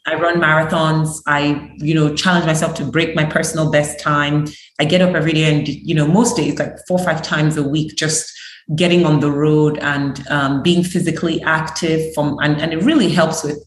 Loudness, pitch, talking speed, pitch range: -16 LUFS, 155 Hz, 210 wpm, 150-165 Hz